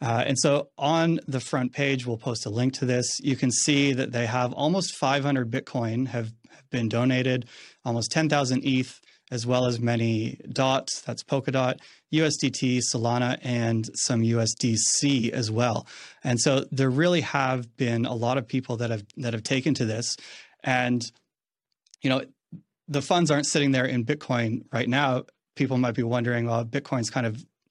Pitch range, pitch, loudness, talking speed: 120-140 Hz, 125 Hz, -25 LUFS, 170 wpm